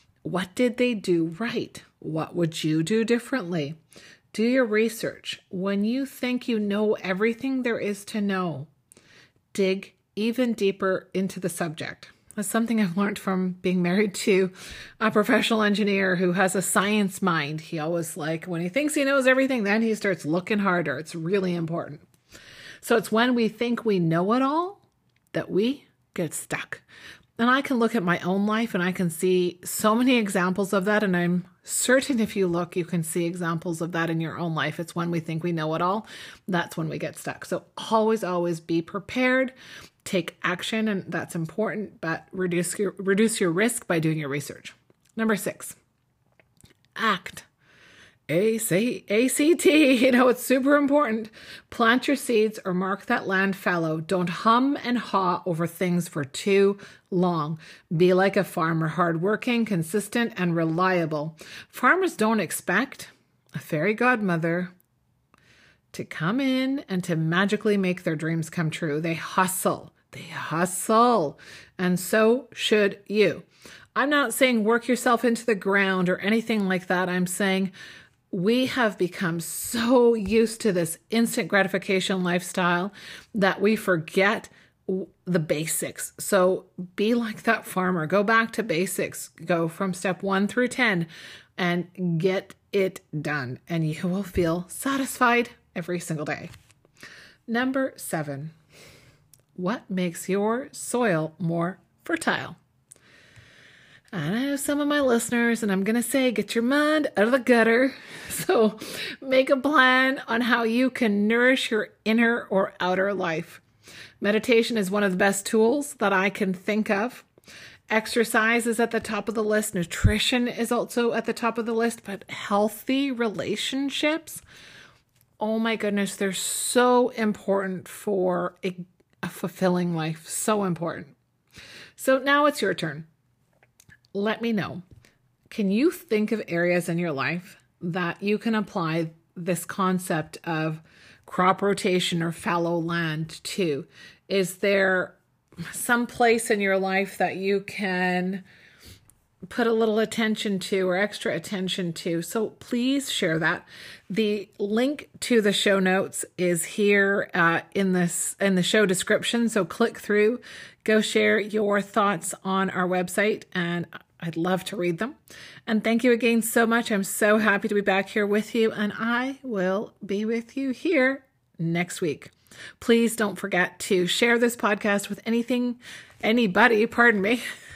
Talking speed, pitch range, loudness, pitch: 155 wpm, 175-230 Hz, -24 LUFS, 200 Hz